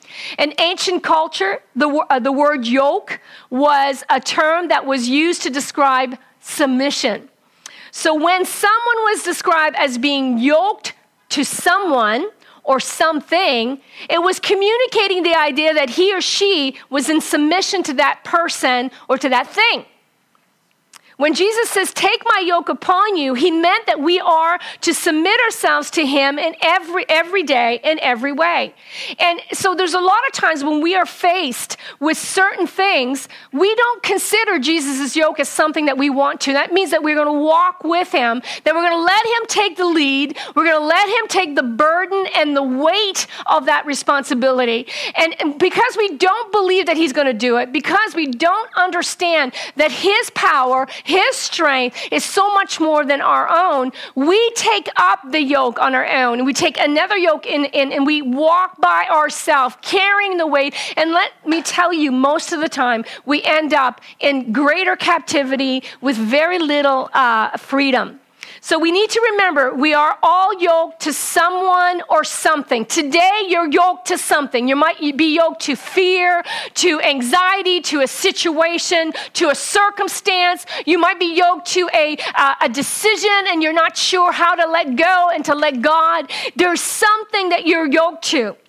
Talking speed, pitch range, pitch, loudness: 175 wpm, 285-365 Hz, 325 Hz, -15 LUFS